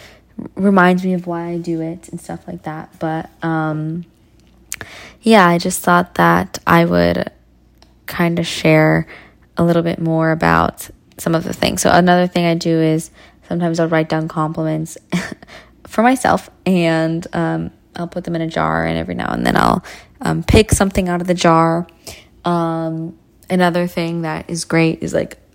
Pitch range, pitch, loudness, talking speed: 155-175 Hz, 165 Hz, -16 LUFS, 175 wpm